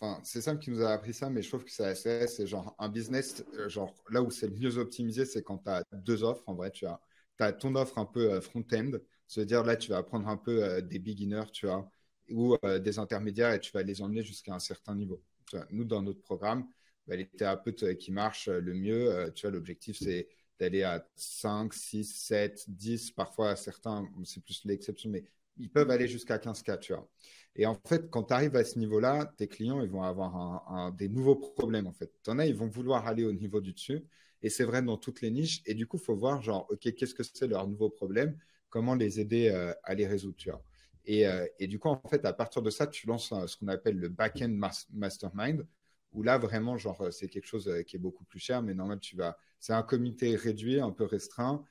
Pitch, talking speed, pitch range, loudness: 110 Hz, 235 wpm, 100-125 Hz, -34 LUFS